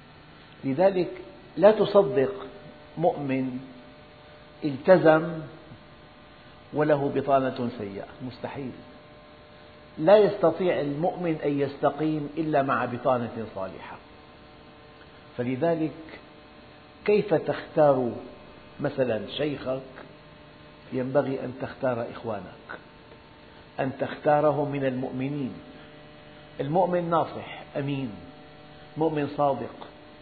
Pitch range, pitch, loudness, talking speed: 130-155 Hz, 145 Hz, -26 LUFS, 70 wpm